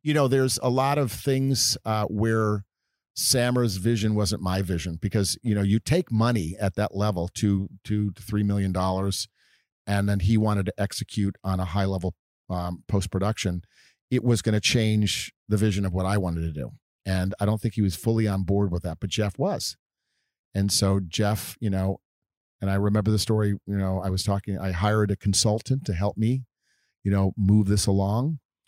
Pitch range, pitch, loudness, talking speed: 95-110 Hz, 105 Hz, -25 LUFS, 200 wpm